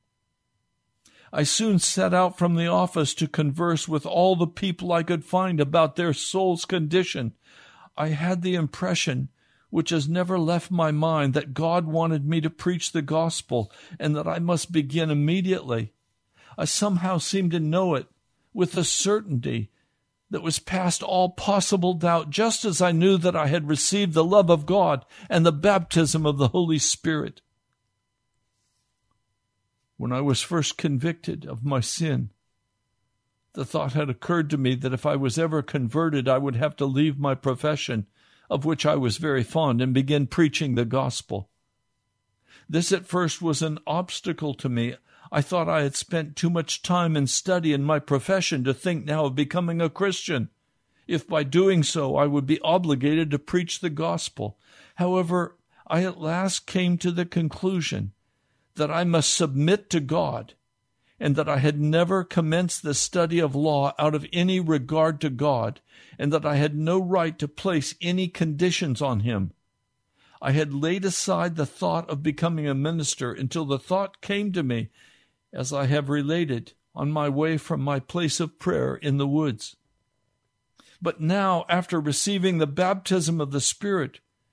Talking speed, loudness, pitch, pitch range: 170 wpm, -24 LUFS, 155 Hz, 135-175 Hz